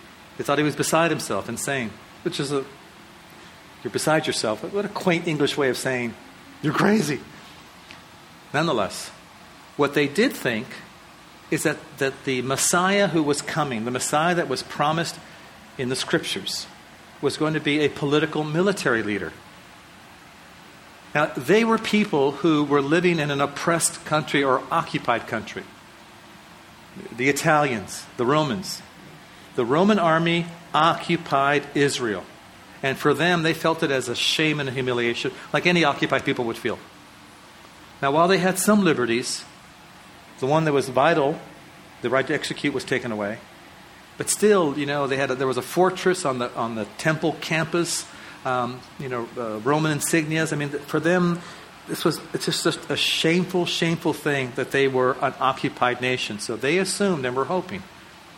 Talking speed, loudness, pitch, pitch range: 165 wpm, -23 LUFS, 150 Hz, 135-170 Hz